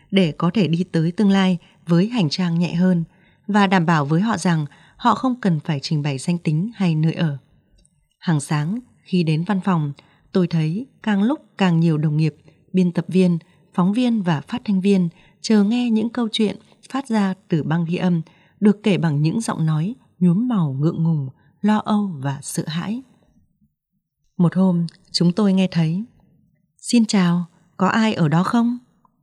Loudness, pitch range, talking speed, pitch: -20 LUFS, 165-205 Hz, 185 wpm, 180 Hz